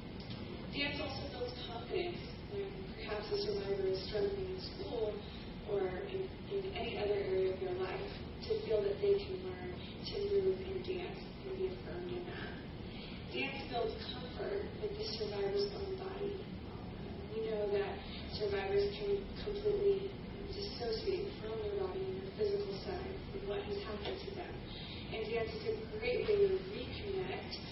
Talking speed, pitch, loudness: 155 wpm, 215 Hz, -39 LUFS